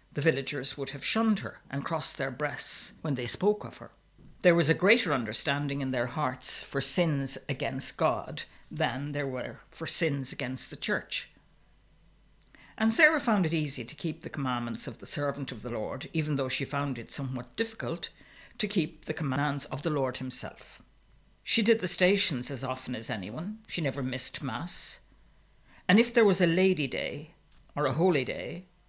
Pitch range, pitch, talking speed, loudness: 135-175 Hz, 145 Hz, 185 wpm, -29 LUFS